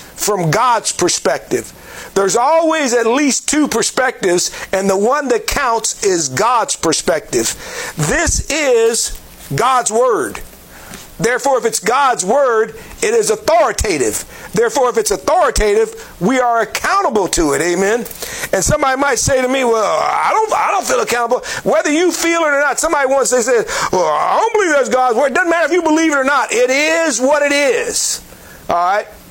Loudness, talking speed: -14 LUFS, 175 wpm